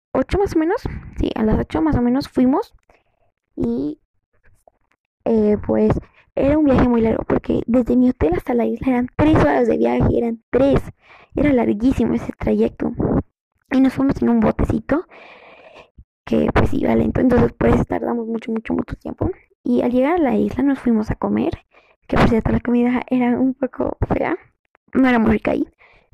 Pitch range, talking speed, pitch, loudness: 235-275 Hz, 185 wpm, 255 Hz, -19 LUFS